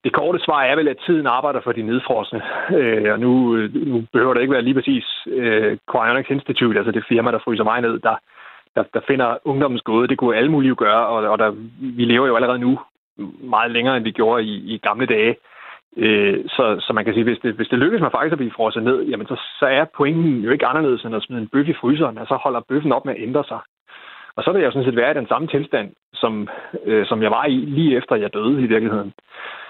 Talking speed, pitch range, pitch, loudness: 250 wpm, 110-135 Hz, 120 Hz, -18 LUFS